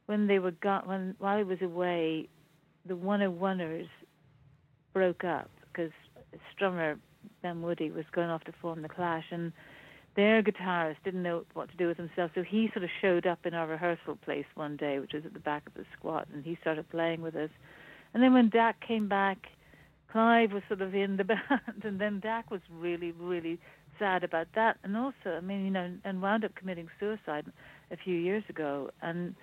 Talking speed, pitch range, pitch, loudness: 205 wpm, 165-200 Hz, 175 Hz, -32 LUFS